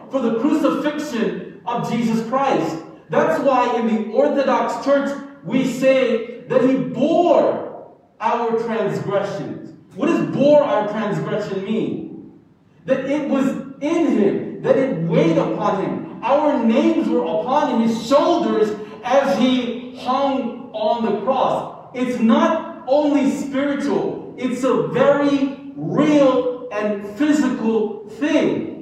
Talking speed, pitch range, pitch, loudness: 125 wpm, 225-280 Hz, 255 Hz, -19 LUFS